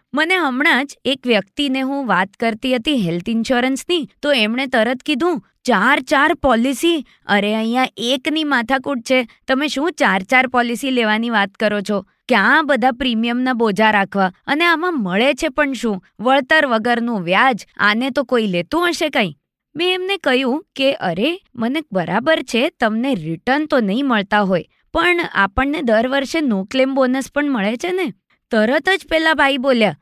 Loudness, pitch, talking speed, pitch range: -17 LUFS, 260 Hz, 165 wpm, 220-290 Hz